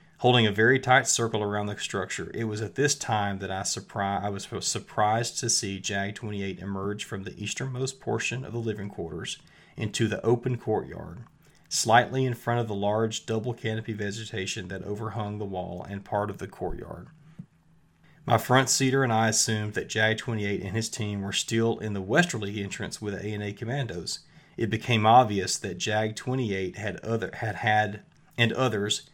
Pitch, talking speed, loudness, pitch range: 110 Hz, 185 wpm, -27 LUFS, 100-120 Hz